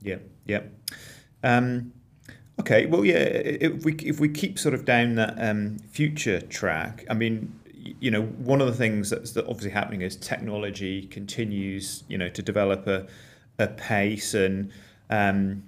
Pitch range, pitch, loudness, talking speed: 100-125 Hz, 110 Hz, -26 LUFS, 155 wpm